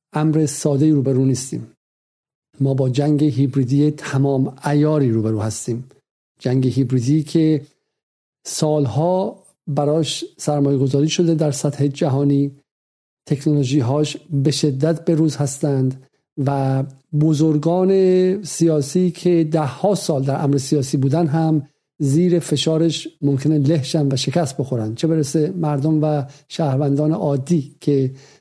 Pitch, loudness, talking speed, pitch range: 150 Hz, -19 LUFS, 125 wpm, 140-160 Hz